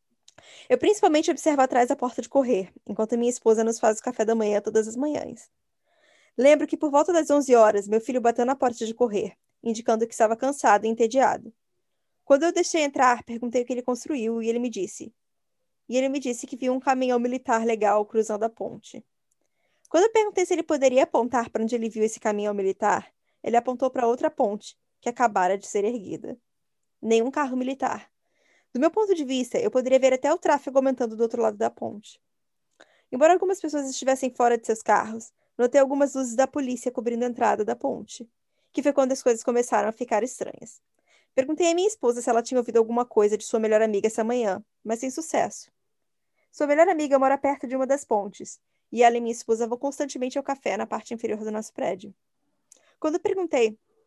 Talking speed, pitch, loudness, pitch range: 200 wpm, 250 Hz, -24 LUFS, 225-280 Hz